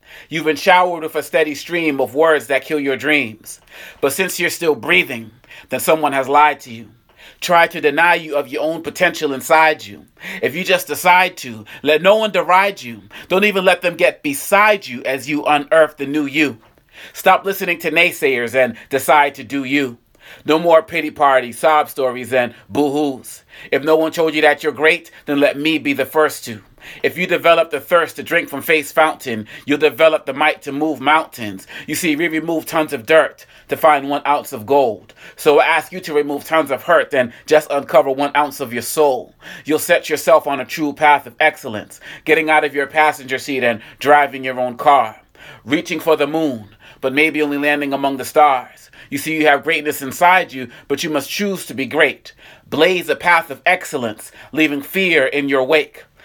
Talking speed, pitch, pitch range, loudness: 205 wpm, 150 Hz, 135-160 Hz, -16 LUFS